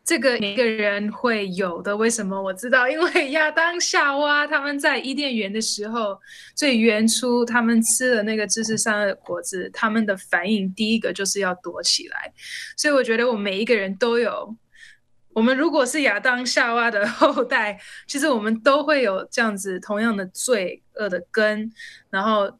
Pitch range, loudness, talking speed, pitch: 205-280 Hz, -21 LUFS, 275 characters per minute, 230 Hz